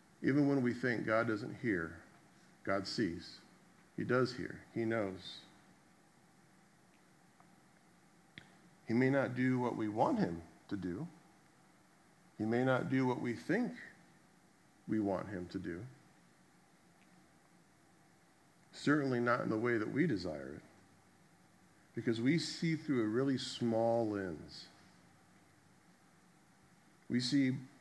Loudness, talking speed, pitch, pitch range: -36 LUFS, 120 wpm, 130 Hz, 115-155 Hz